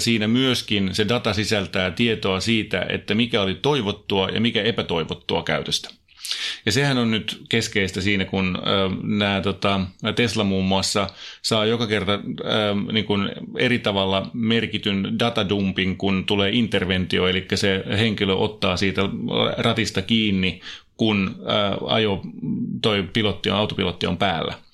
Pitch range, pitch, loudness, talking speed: 95-110 Hz, 105 Hz, -22 LUFS, 135 wpm